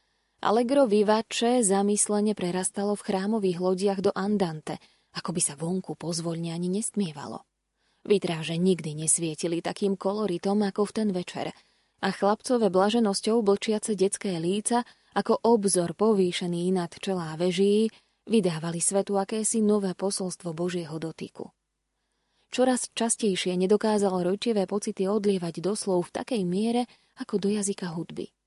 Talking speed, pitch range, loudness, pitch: 125 wpm, 180-210 Hz, -26 LUFS, 195 Hz